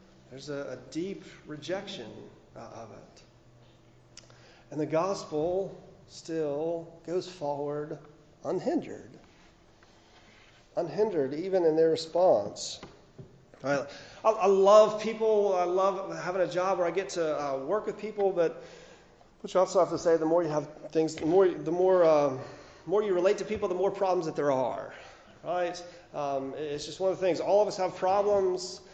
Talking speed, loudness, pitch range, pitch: 160 wpm, -28 LUFS, 150-190 Hz, 175 Hz